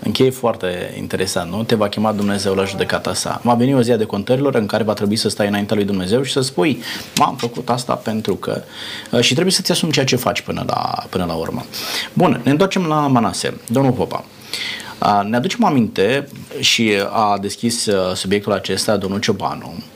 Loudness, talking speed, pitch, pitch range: -18 LUFS, 190 wpm, 110 Hz, 100-125 Hz